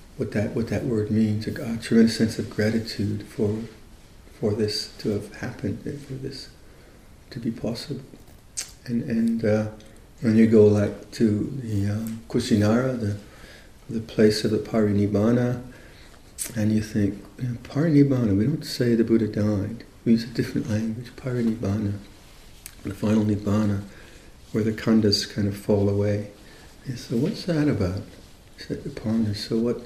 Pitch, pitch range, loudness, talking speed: 110 Hz, 105-115 Hz, -24 LUFS, 155 wpm